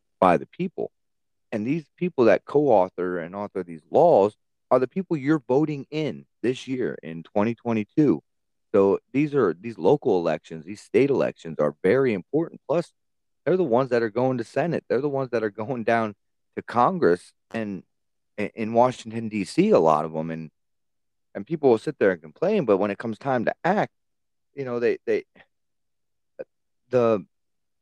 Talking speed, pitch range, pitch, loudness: 175 wpm, 95-135 Hz, 115 Hz, -24 LUFS